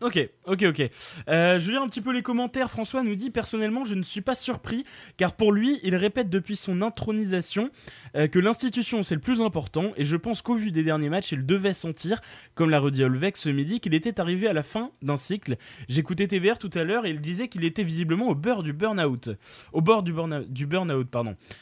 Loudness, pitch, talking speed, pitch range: -26 LUFS, 185 Hz, 230 wpm, 155-225 Hz